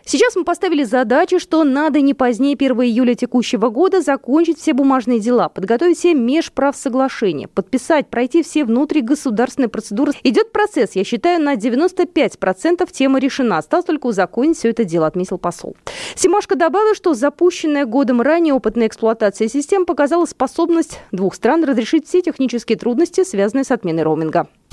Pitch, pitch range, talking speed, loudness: 275 Hz, 235-330 Hz, 150 wpm, -16 LUFS